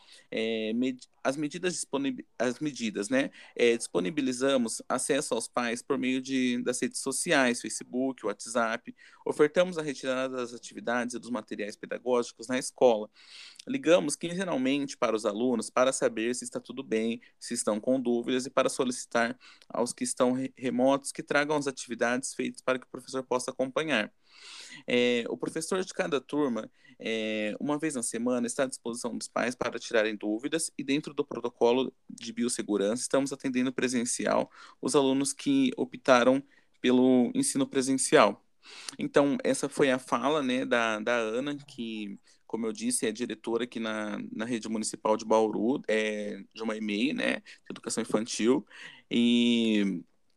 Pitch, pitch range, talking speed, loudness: 125 Hz, 115-140 Hz, 155 wpm, -29 LUFS